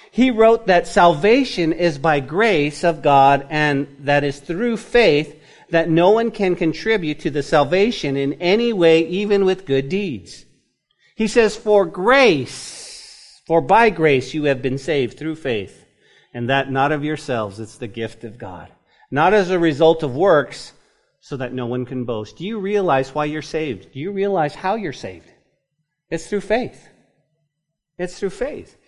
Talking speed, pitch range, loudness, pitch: 170 wpm, 140-195 Hz, -18 LUFS, 160 Hz